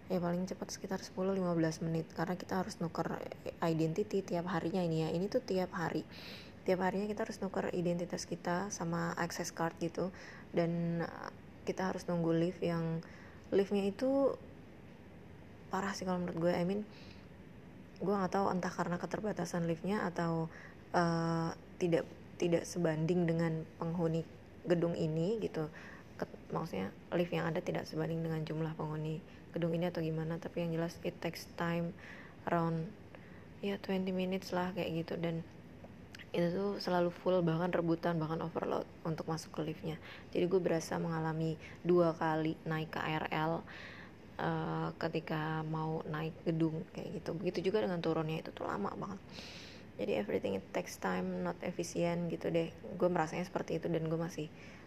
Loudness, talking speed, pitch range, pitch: -37 LUFS, 155 wpm, 165-180 Hz, 170 Hz